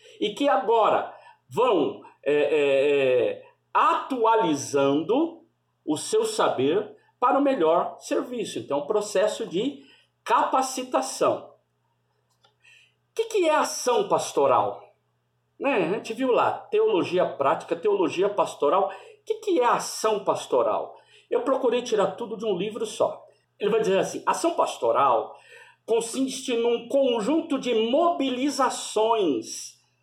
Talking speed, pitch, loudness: 120 wpm, 275 Hz, -24 LUFS